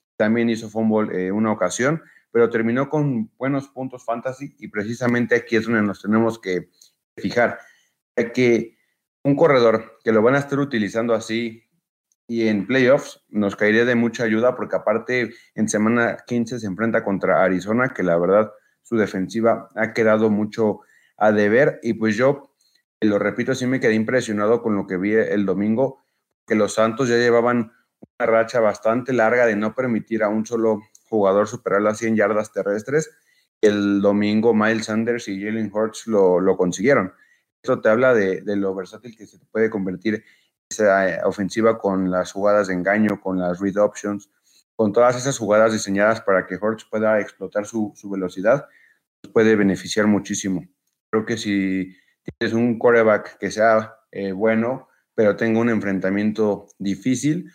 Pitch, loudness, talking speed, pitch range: 110 Hz, -20 LUFS, 165 wpm, 100-115 Hz